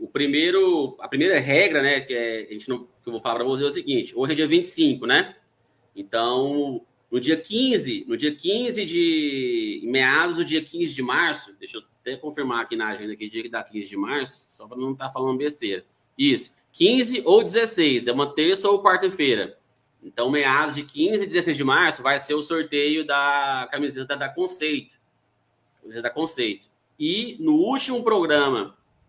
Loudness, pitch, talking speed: -22 LUFS, 165 Hz, 195 wpm